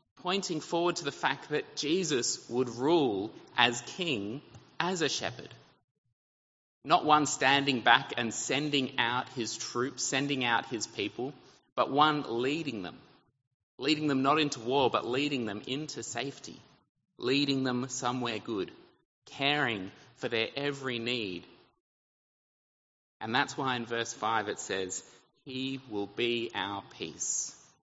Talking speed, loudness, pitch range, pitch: 135 wpm, -31 LUFS, 115-140 Hz, 130 Hz